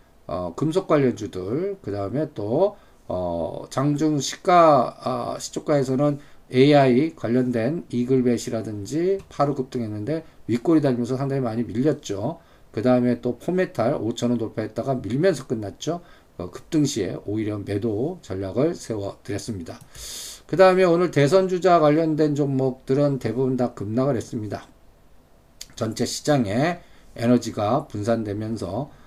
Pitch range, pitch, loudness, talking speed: 110-150 Hz, 125 Hz, -23 LUFS, 290 characters per minute